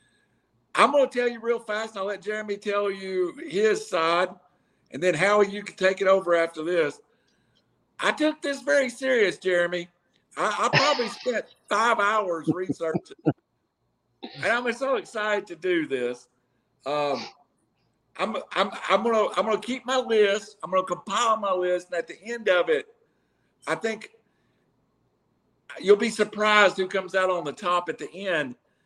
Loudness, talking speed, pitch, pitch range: -25 LUFS, 175 wpm, 205 Hz, 175-235 Hz